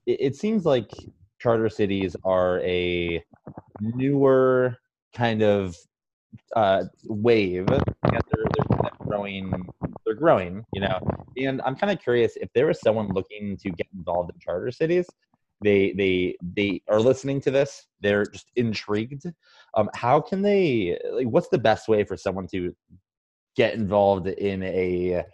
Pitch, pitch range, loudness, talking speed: 105 Hz, 95-130 Hz, -24 LUFS, 145 wpm